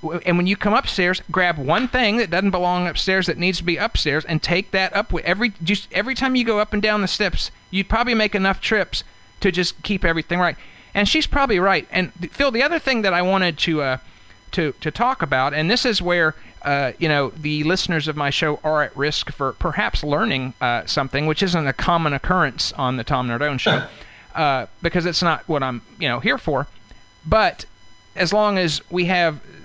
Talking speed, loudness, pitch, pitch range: 215 wpm, -20 LUFS, 175 Hz, 150-200 Hz